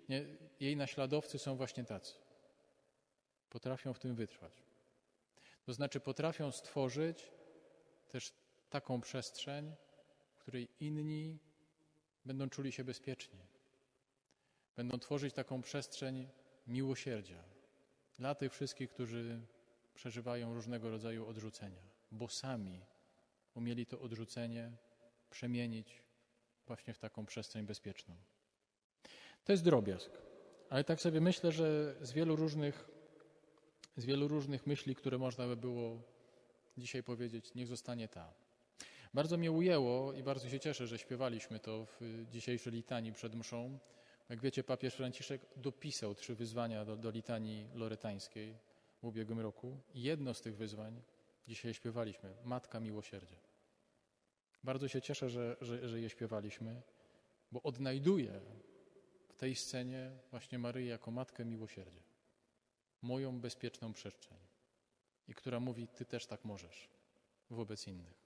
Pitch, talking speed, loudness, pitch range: 125 Hz, 120 wpm, -43 LUFS, 115-135 Hz